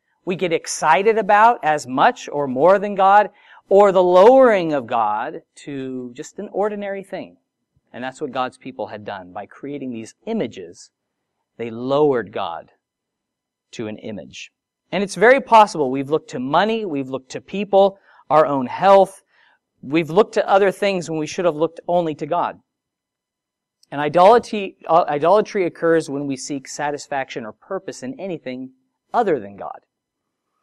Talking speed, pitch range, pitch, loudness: 155 wpm, 140-195 Hz, 165 Hz, -18 LUFS